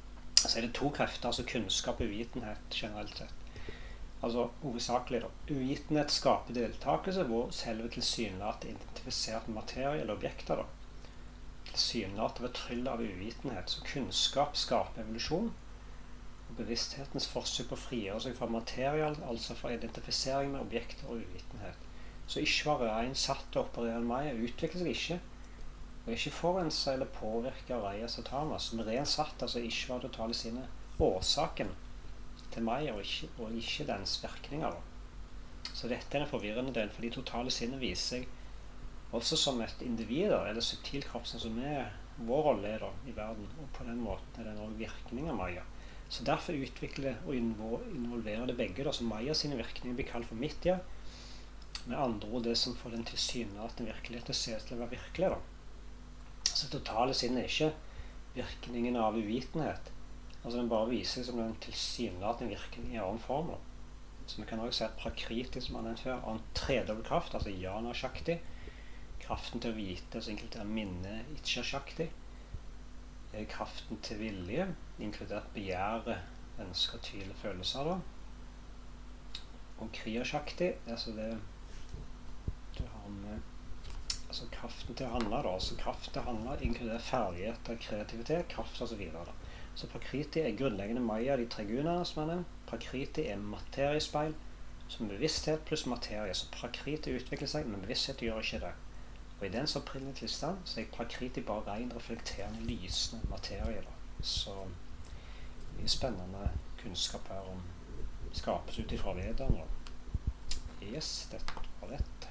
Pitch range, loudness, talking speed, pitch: 100-125 Hz, -37 LUFS, 145 wpm, 115 Hz